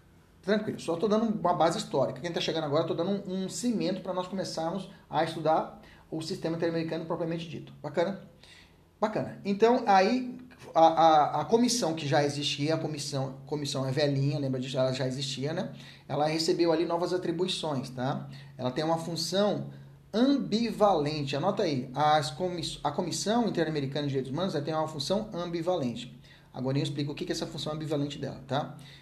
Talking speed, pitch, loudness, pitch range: 180 wpm, 160 Hz, -29 LUFS, 145-185 Hz